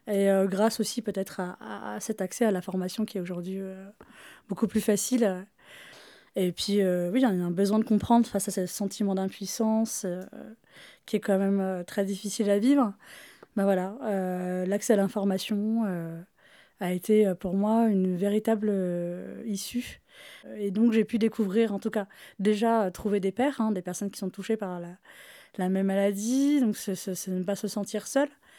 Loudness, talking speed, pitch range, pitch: -28 LUFS, 195 wpm, 190-220 Hz, 200 Hz